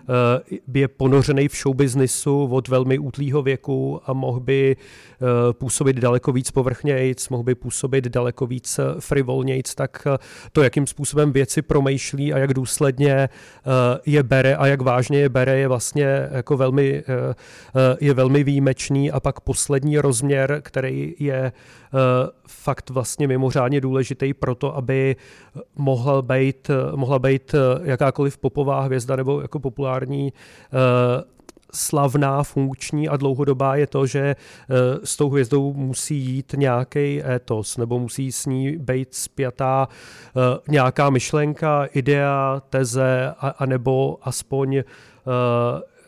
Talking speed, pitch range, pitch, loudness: 120 wpm, 130-140 Hz, 135 Hz, -20 LUFS